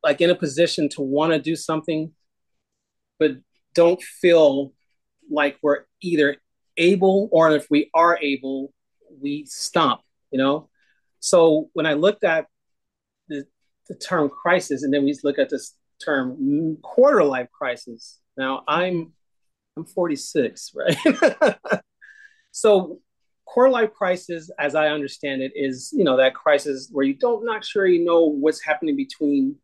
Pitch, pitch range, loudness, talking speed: 155 Hz, 140-180 Hz, -21 LUFS, 145 wpm